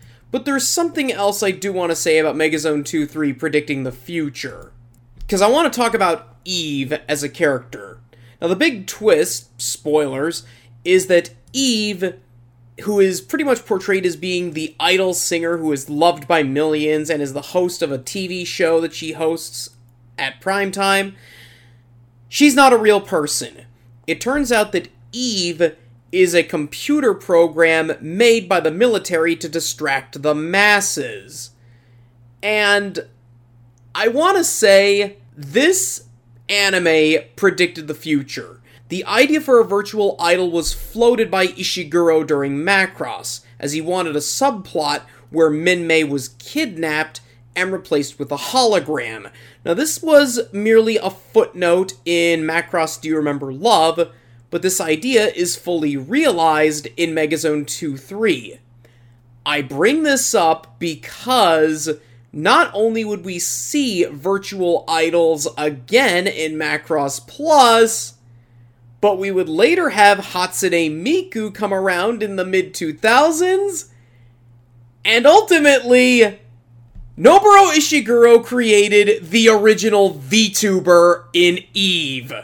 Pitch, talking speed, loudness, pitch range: 170 Hz, 130 wpm, -16 LUFS, 140-205 Hz